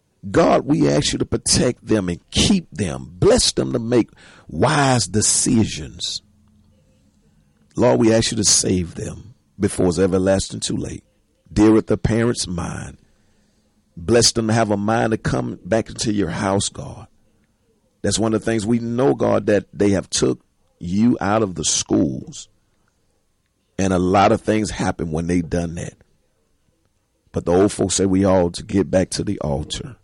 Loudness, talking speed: -19 LUFS, 170 wpm